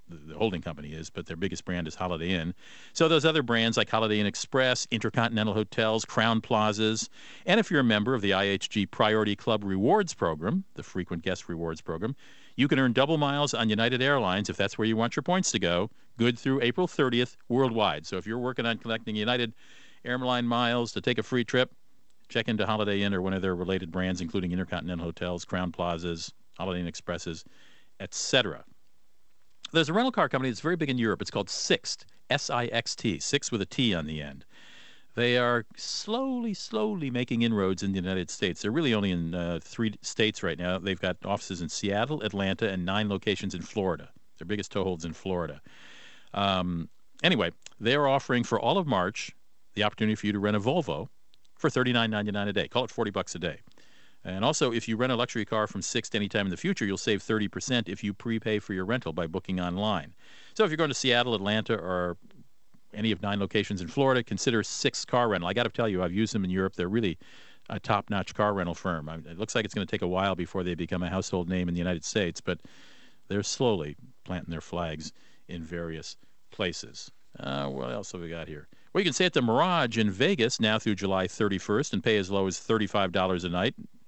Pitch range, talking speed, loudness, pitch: 90-120 Hz, 215 wpm, -28 LUFS, 105 Hz